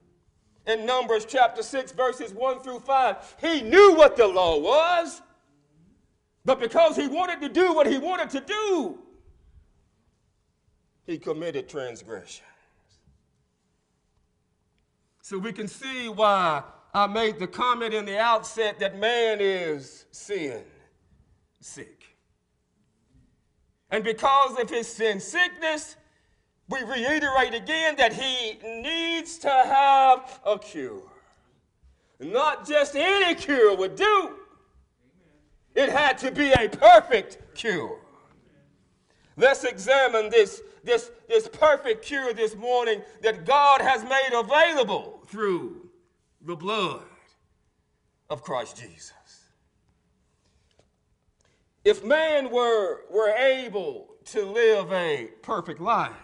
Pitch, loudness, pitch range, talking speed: 270 Hz, -23 LUFS, 225-350 Hz, 110 wpm